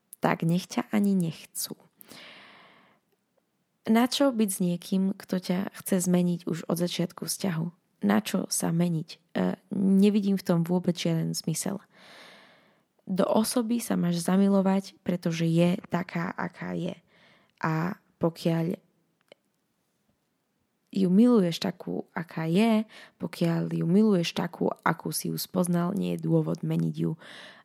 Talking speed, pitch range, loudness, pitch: 120 wpm, 170-200 Hz, -27 LUFS, 185 Hz